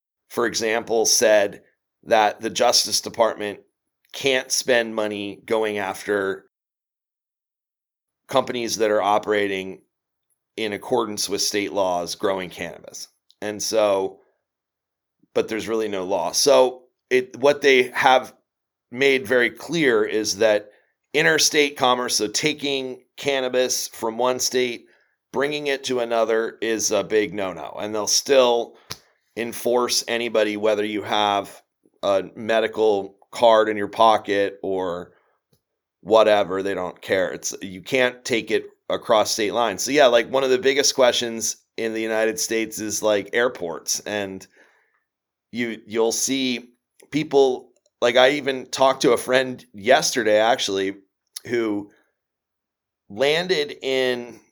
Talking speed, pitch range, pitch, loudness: 125 wpm, 105-125 Hz, 115 Hz, -21 LUFS